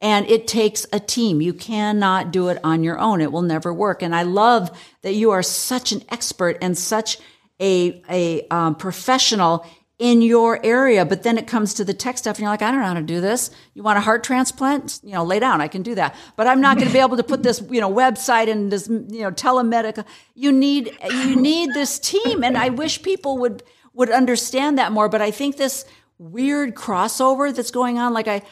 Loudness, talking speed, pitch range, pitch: -19 LUFS, 230 wpm, 190-255 Hz, 225 Hz